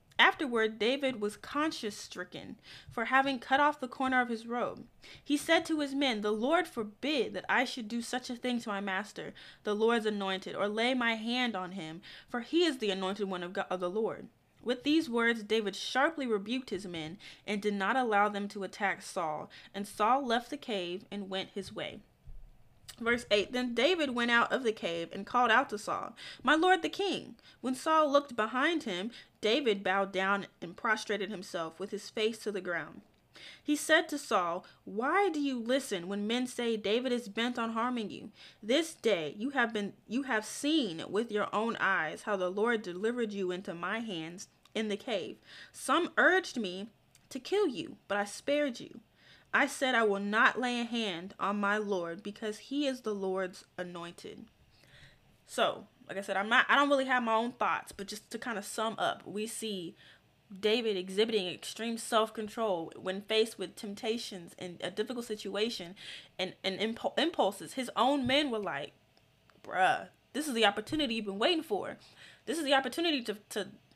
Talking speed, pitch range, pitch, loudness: 190 wpm, 195-255 Hz, 220 Hz, -32 LUFS